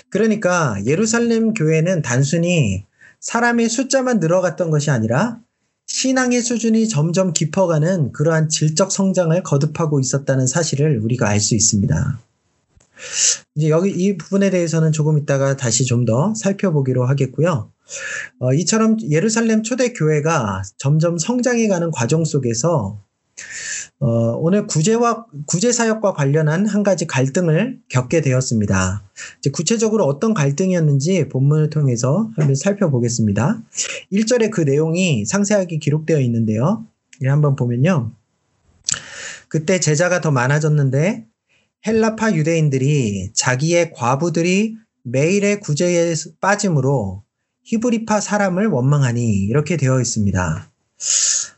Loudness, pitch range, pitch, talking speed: -17 LUFS, 135-195 Hz, 160 Hz, 300 characters per minute